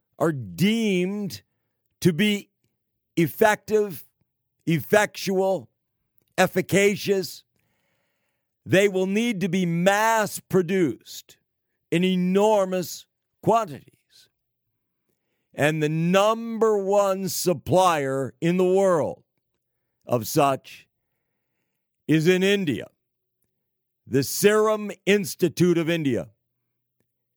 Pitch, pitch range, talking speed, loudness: 180 Hz, 130-195 Hz, 75 wpm, -23 LUFS